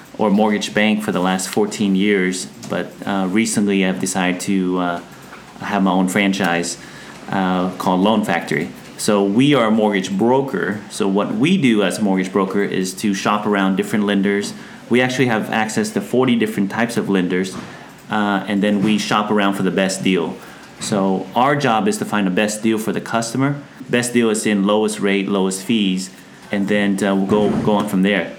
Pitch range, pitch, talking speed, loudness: 95-105 Hz, 100 Hz, 195 wpm, -18 LUFS